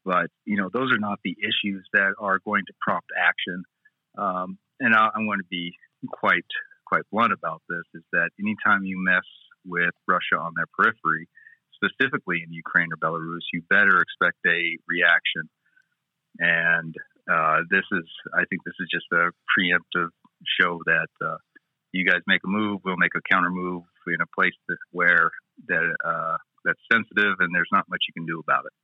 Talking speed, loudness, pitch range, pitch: 180 wpm, -23 LUFS, 90-150 Hz, 95 Hz